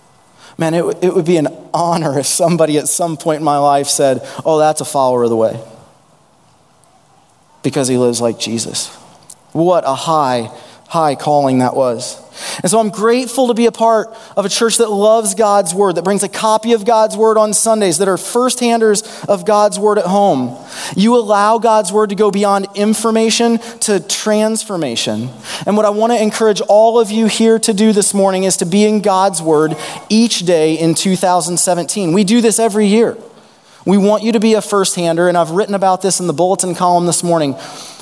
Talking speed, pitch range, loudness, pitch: 200 wpm, 160-215 Hz, -13 LUFS, 195 Hz